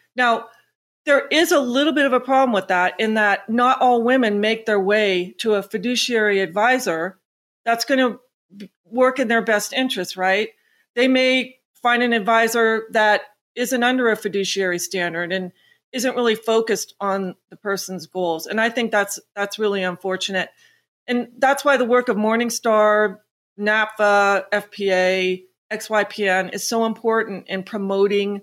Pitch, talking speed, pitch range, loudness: 215 Hz, 155 wpm, 195-245 Hz, -19 LUFS